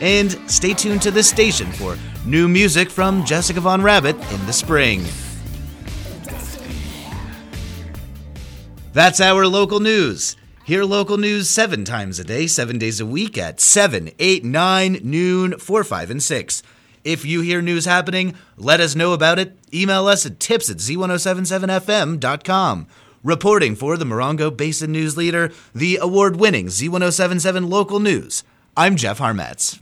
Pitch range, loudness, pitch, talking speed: 120-190 Hz, -17 LUFS, 170 Hz, 145 wpm